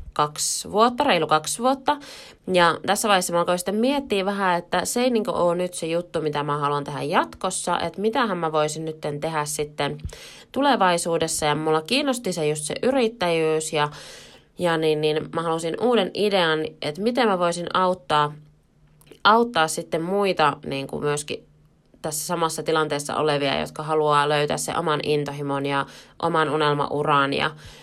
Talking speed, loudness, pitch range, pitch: 160 wpm, -23 LUFS, 150-190 Hz, 165 Hz